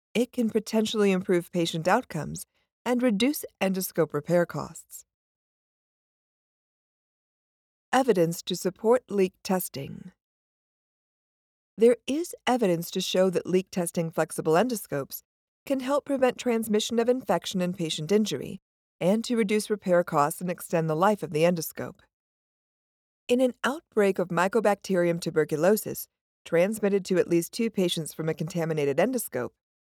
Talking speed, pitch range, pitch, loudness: 130 wpm, 170-230 Hz, 190 Hz, -26 LUFS